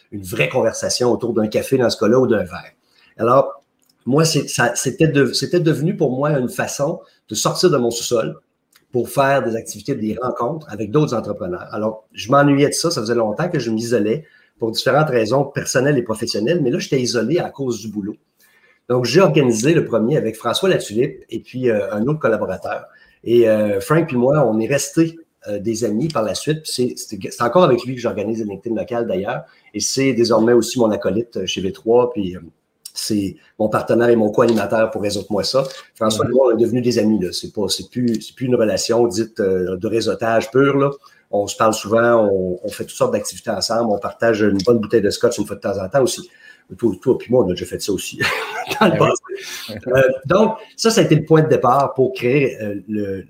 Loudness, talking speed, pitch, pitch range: -18 LUFS, 210 wpm, 120 Hz, 110-140 Hz